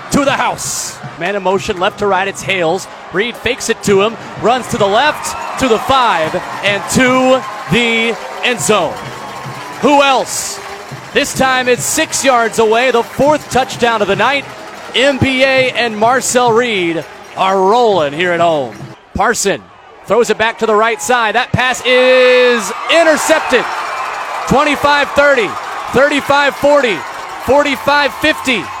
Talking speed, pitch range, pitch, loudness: 135 wpm, 215-270 Hz, 245 Hz, -12 LUFS